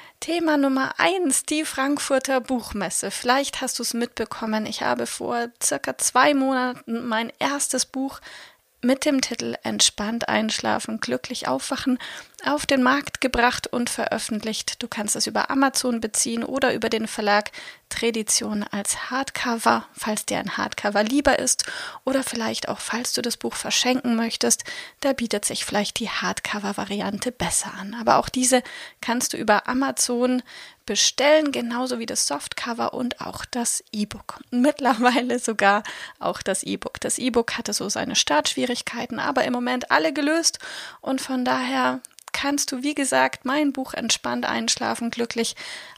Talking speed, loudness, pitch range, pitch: 150 wpm, -23 LUFS, 225-270 Hz, 250 Hz